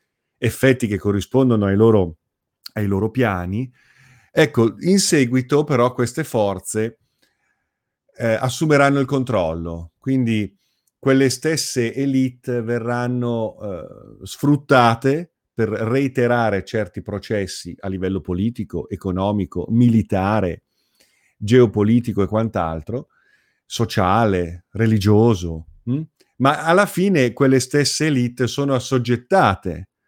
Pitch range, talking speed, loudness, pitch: 100-130 Hz, 95 wpm, -19 LUFS, 115 Hz